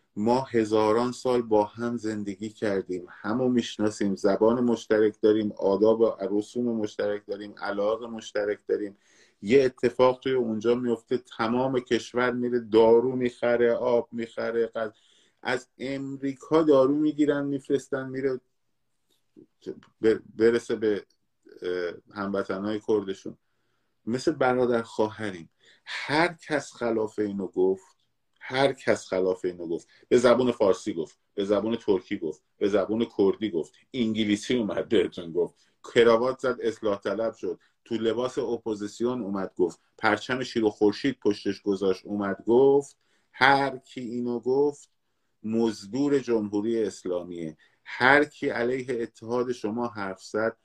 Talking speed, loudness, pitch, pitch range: 125 wpm, -26 LUFS, 115 Hz, 105-125 Hz